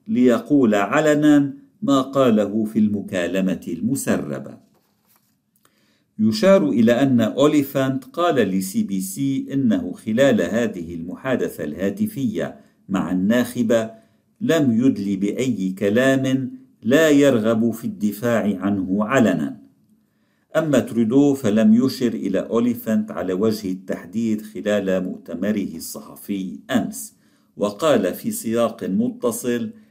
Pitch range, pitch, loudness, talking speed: 105-140 Hz, 120 Hz, -20 LUFS, 100 wpm